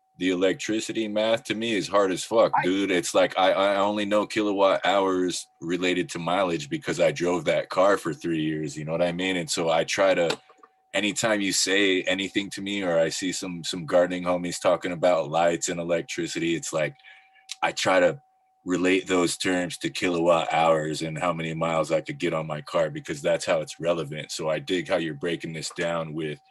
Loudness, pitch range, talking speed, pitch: -25 LUFS, 80-95 Hz, 210 wpm, 90 Hz